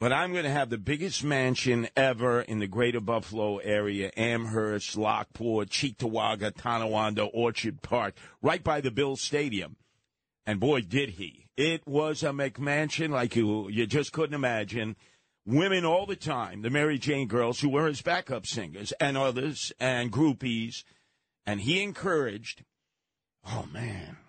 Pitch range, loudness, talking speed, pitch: 110-145 Hz, -29 LUFS, 140 wpm, 125 Hz